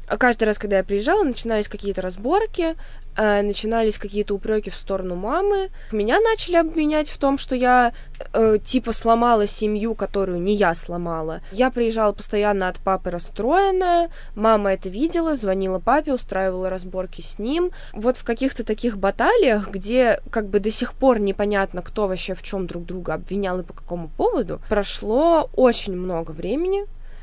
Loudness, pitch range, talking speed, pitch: -21 LUFS, 190-255 Hz, 160 wpm, 215 Hz